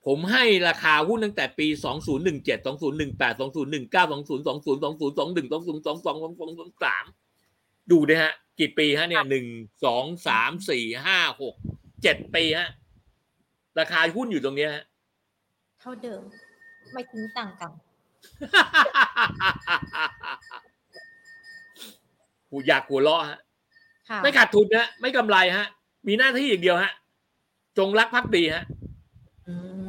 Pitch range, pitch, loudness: 155-240 Hz, 175 Hz, -23 LUFS